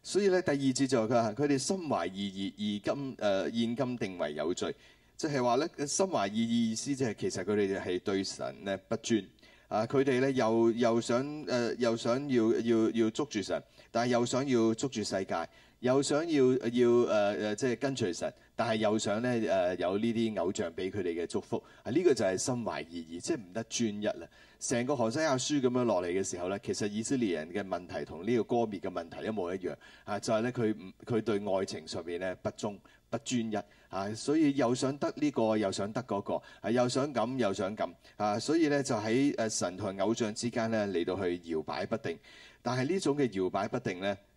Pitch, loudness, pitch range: 115 Hz, -32 LUFS, 105-130 Hz